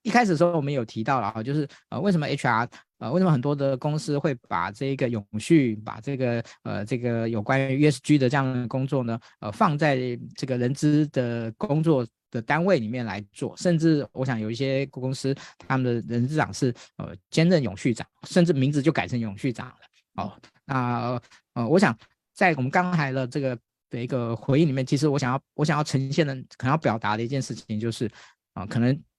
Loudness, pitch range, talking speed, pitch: -25 LUFS, 120-150 Hz, 310 characters per minute, 135 Hz